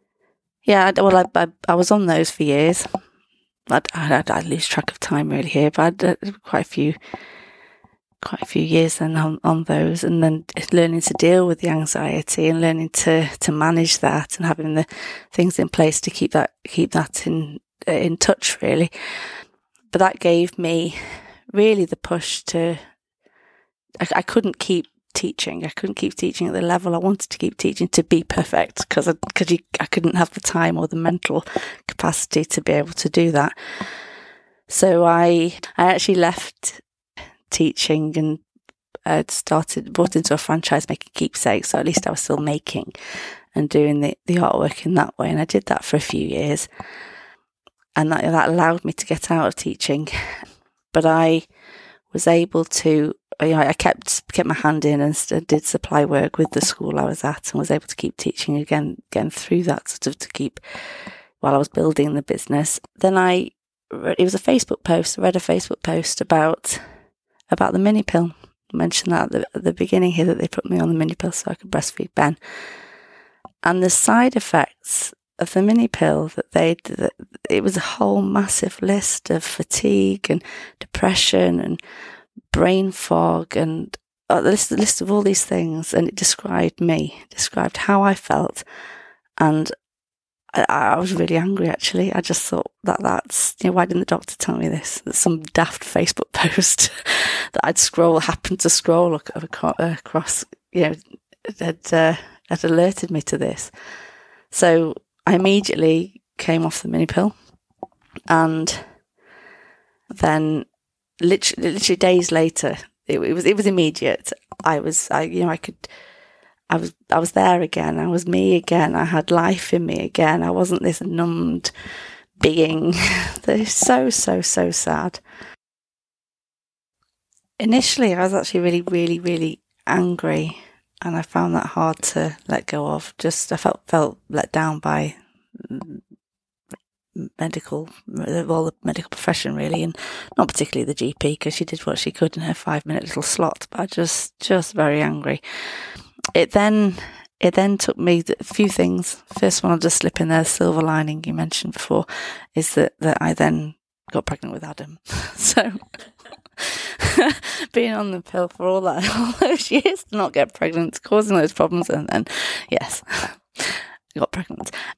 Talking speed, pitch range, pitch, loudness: 175 wpm, 150-180 Hz, 165 Hz, -19 LUFS